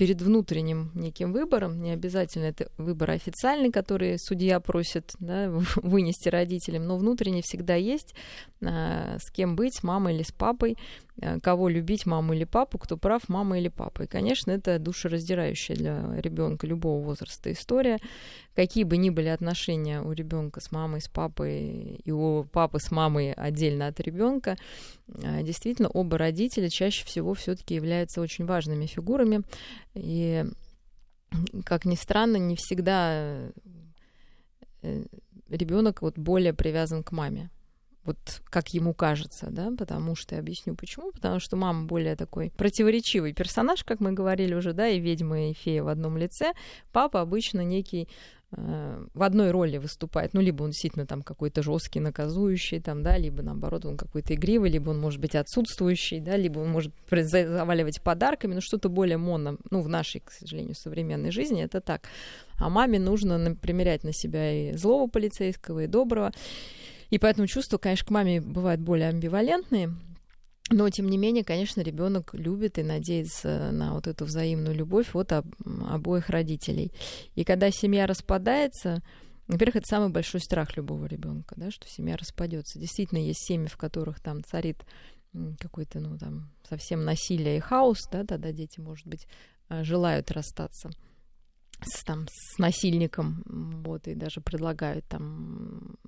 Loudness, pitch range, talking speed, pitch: -28 LUFS, 155-195 Hz, 155 wpm, 170 Hz